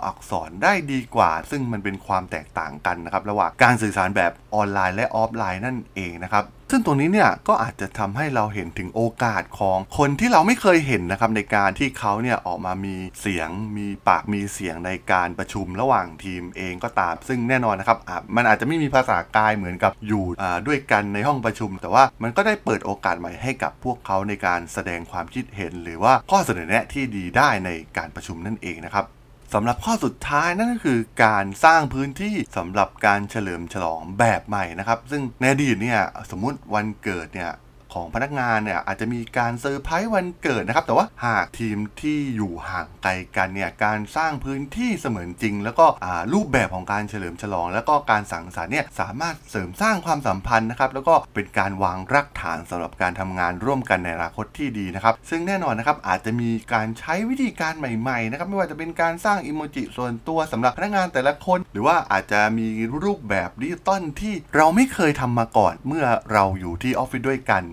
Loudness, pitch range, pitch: -22 LUFS, 95-135 Hz, 110 Hz